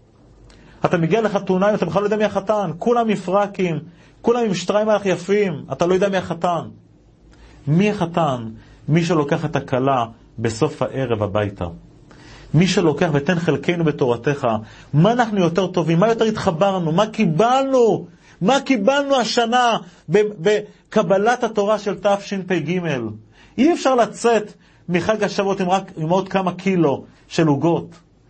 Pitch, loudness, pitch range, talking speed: 185 Hz, -19 LUFS, 155-210 Hz, 140 wpm